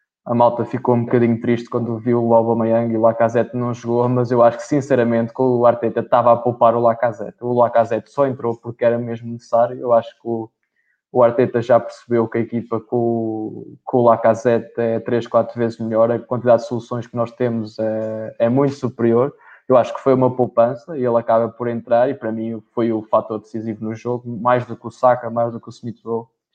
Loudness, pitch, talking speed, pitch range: -18 LUFS, 115 Hz, 220 wpm, 115-120 Hz